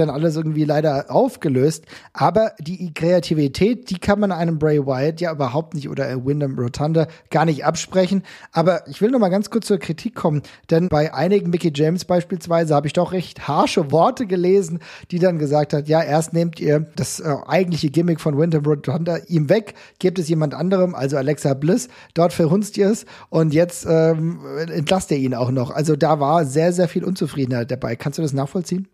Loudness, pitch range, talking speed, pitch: -19 LUFS, 150-185 Hz, 195 wpm, 165 Hz